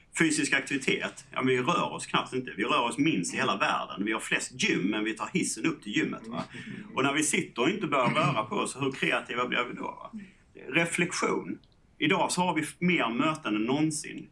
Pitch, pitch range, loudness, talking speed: 155 Hz, 130-180 Hz, -28 LUFS, 220 wpm